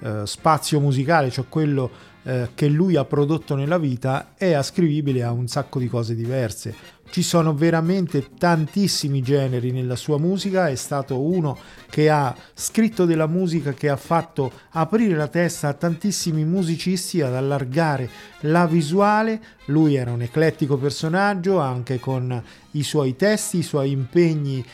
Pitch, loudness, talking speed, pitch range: 150 Hz, -21 LUFS, 150 wpm, 130-170 Hz